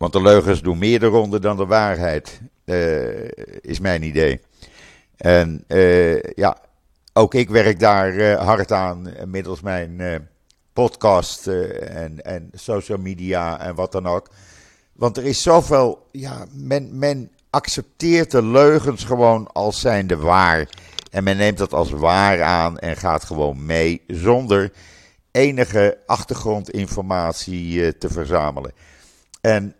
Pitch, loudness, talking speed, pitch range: 95 Hz, -18 LUFS, 140 wpm, 85-110 Hz